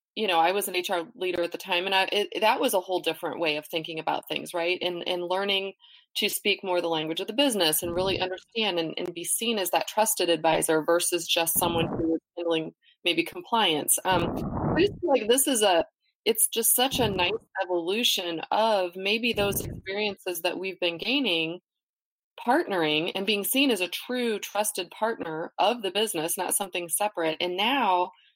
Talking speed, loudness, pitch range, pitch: 195 wpm, -26 LUFS, 170-210 Hz, 185 Hz